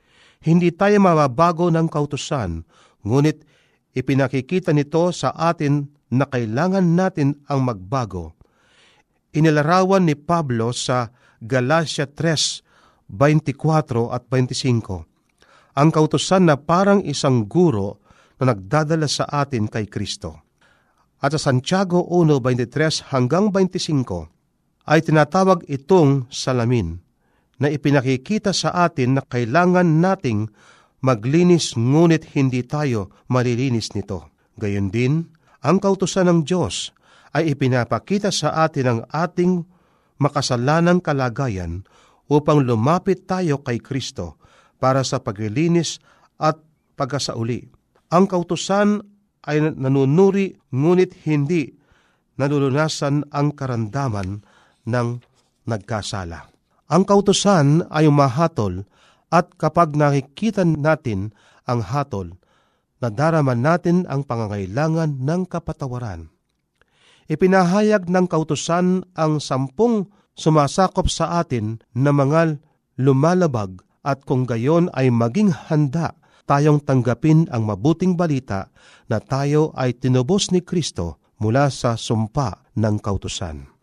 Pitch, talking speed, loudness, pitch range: 145 Hz, 105 wpm, -19 LUFS, 125-165 Hz